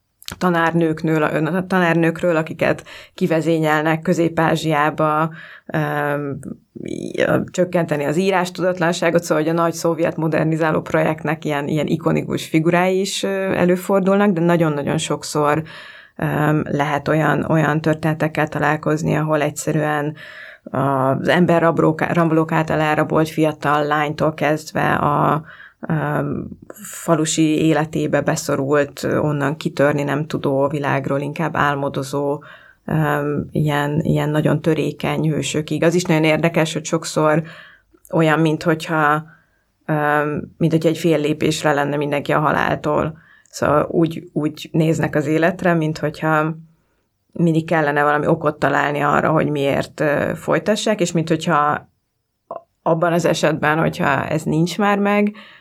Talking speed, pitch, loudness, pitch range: 105 wpm, 155 Hz, -18 LUFS, 150-165 Hz